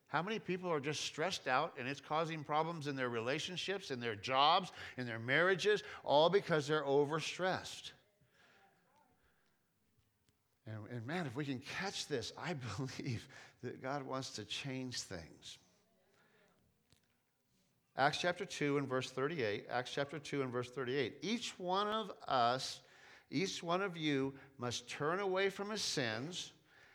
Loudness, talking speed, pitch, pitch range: -38 LUFS, 145 wpm, 145 Hz, 130-175 Hz